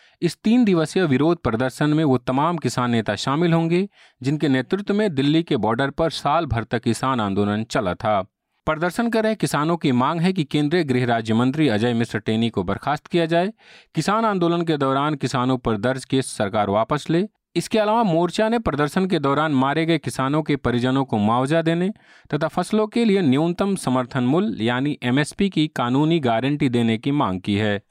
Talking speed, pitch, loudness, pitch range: 190 wpm, 150 Hz, -21 LUFS, 125-170 Hz